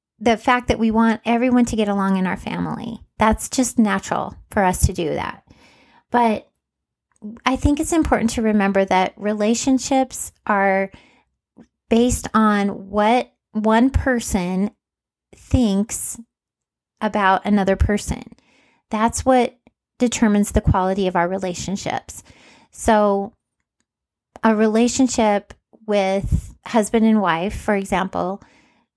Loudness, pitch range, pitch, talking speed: -19 LUFS, 200-240 Hz, 220 Hz, 115 wpm